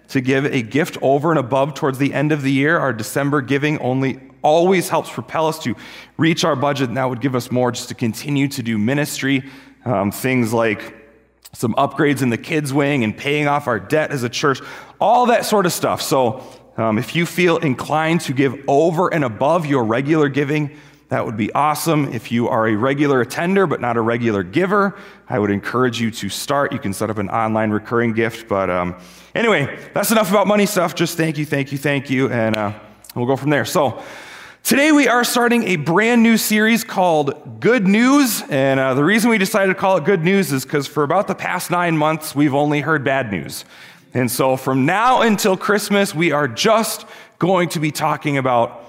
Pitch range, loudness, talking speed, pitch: 125-170 Hz, -18 LUFS, 210 wpm, 145 Hz